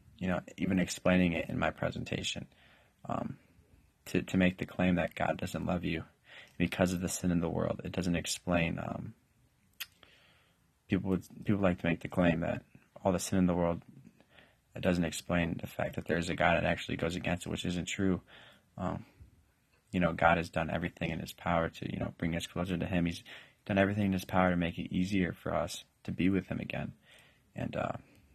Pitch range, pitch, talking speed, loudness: 85-95 Hz, 90 Hz, 210 wpm, -33 LUFS